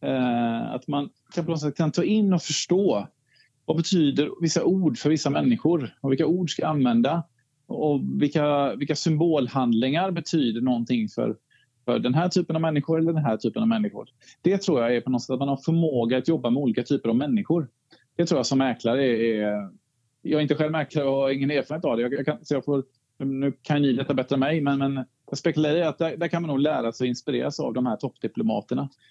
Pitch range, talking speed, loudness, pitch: 130-165 Hz, 215 wpm, -24 LUFS, 145 Hz